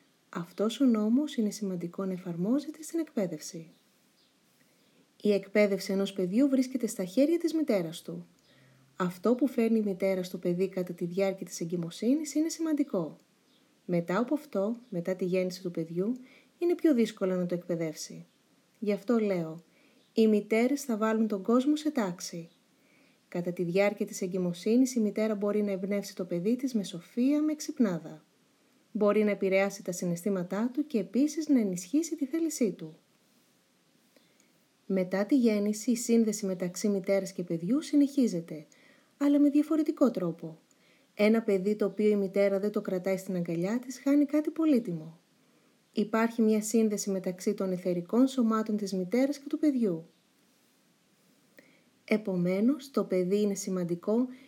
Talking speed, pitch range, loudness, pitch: 150 wpm, 185-255 Hz, -30 LUFS, 210 Hz